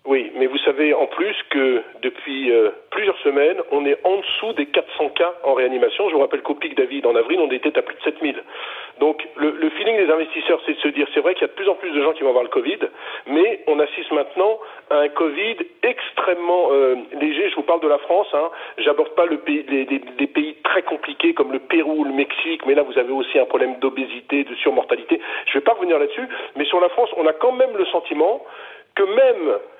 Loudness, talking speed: -19 LUFS, 245 wpm